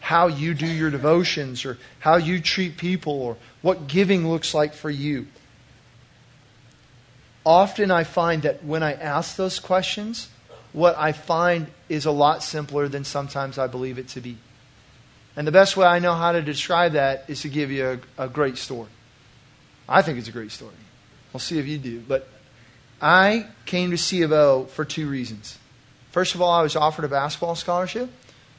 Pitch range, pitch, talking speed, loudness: 130-170 Hz, 150 Hz, 180 wpm, -22 LUFS